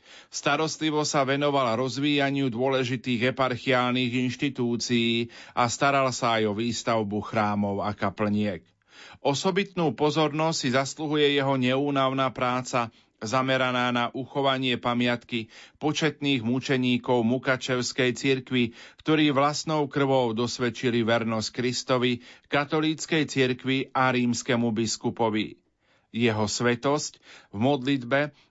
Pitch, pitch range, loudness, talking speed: 130 Hz, 120-140 Hz, -25 LUFS, 95 wpm